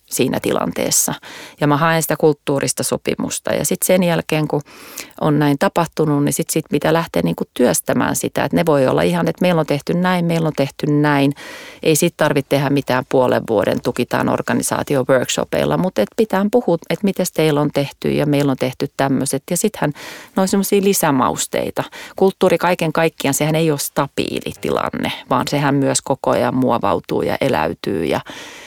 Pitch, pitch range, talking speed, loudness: 155 Hz, 140-175 Hz, 170 wpm, -17 LUFS